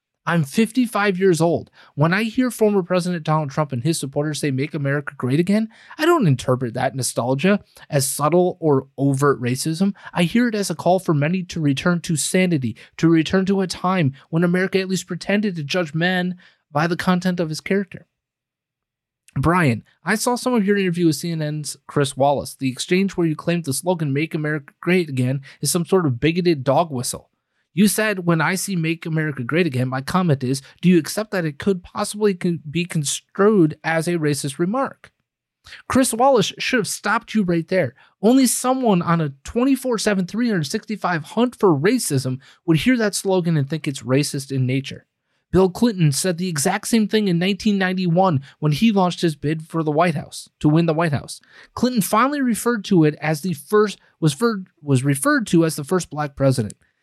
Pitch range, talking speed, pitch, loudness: 150-195 Hz, 195 wpm, 170 Hz, -20 LUFS